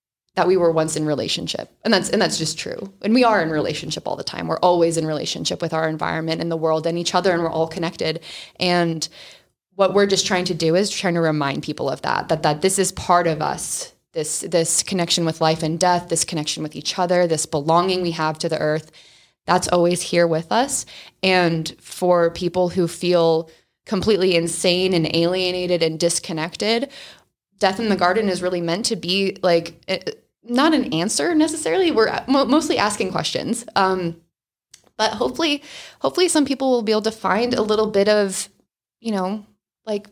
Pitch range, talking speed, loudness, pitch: 165-200 Hz, 195 wpm, -20 LUFS, 180 Hz